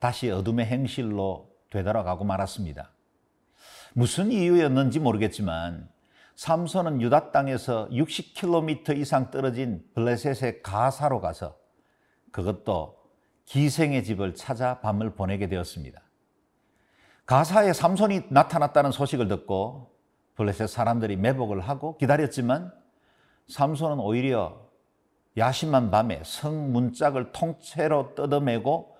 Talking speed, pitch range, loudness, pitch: 265 characters per minute, 105-145 Hz, -26 LUFS, 125 Hz